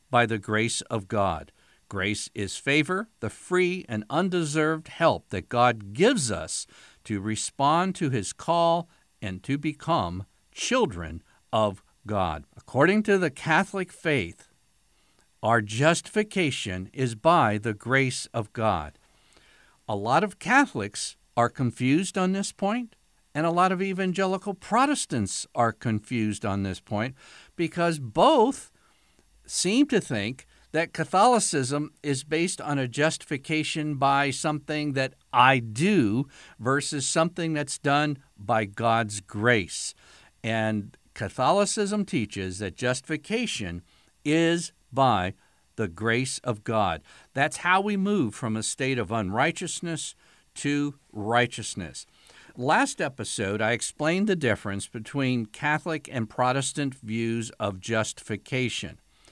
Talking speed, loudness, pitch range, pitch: 120 wpm, -26 LUFS, 110-165 Hz, 135 Hz